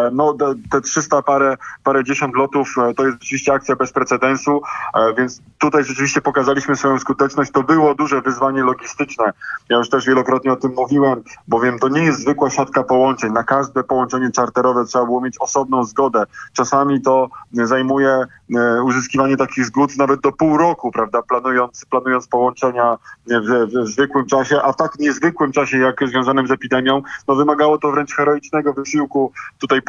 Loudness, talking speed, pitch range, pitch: -17 LUFS, 165 wpm, 125-140 Hz, 135 Hz